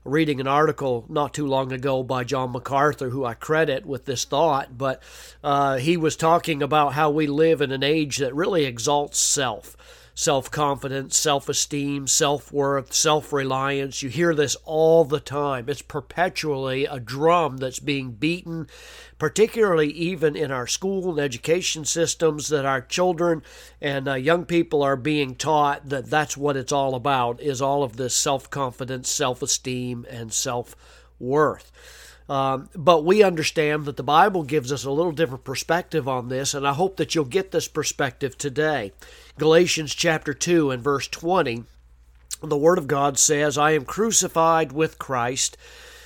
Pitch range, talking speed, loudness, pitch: 135-160 Hz, 165 wpm, -22 LUFS, 145 Hz